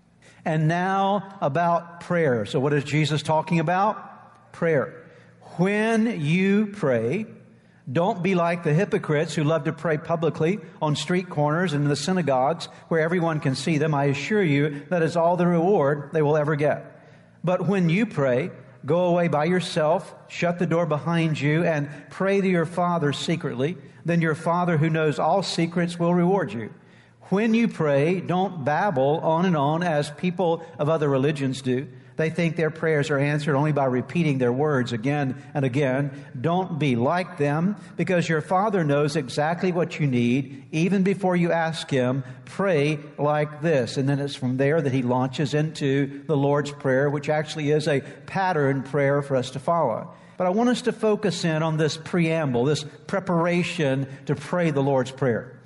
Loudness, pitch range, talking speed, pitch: -23 LUFS, 145-175 Hz, 175 wpm, 155 Hz